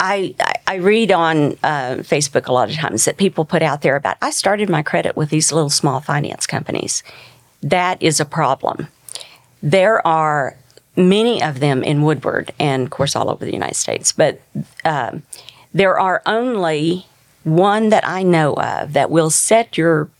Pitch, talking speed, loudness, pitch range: 160 Hz, 175 wpm, -16 LUFS, 145-185 Hz